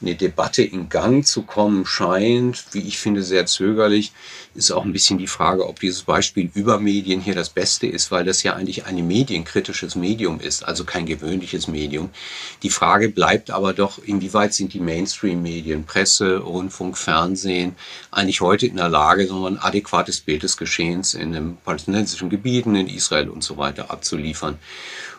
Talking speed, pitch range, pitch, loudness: 170 wpm, 90-100 Hz, 95 Hz, -20 LUFS